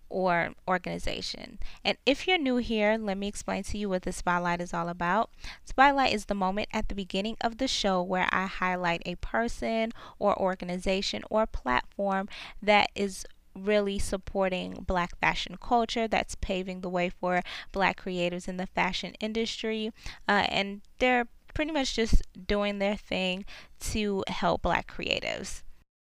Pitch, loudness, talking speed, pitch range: 195 Hz, -29 LUFS, 155 wpm, 180-220 Hz